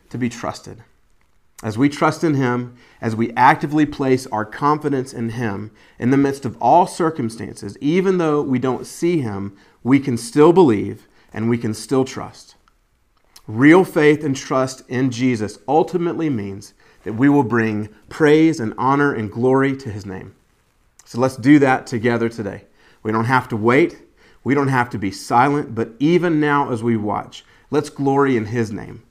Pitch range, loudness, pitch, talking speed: 115-145 Hz, -18 LUFS, 130 Hz, 175 wpm